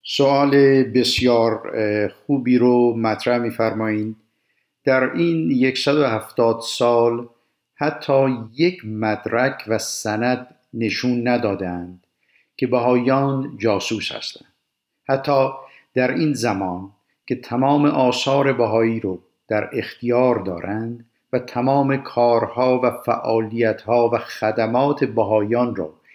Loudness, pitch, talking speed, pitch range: -20 LUFS, 120 Hz, 95 wpm, 110-130 Hz